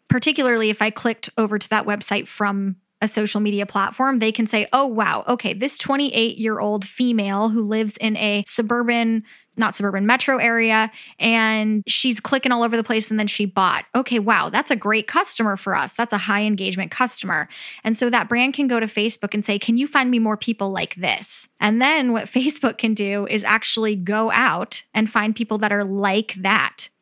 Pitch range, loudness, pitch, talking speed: 210-240 Hz, -20 LUFS, 220 Hz, 205 wpm